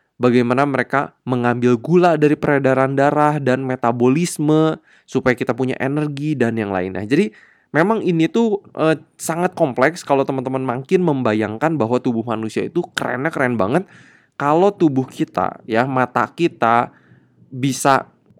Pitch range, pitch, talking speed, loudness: 125-155 Hz, 135 Hz, 135 wpm, -18 LUFS